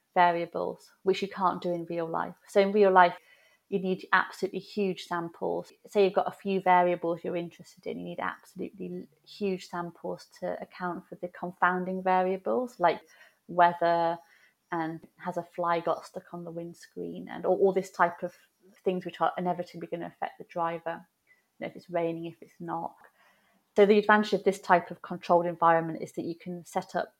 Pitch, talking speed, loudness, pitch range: 180 Hz, 190 wpm, -29 LUFS, 170-190 Hz